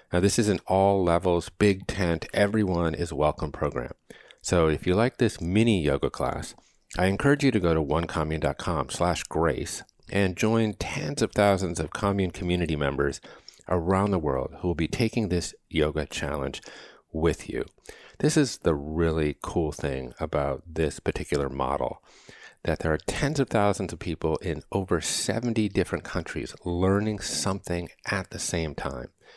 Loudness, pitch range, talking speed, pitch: -27 LUFS, 80-100 Hz, 155 wpm, 90 Hz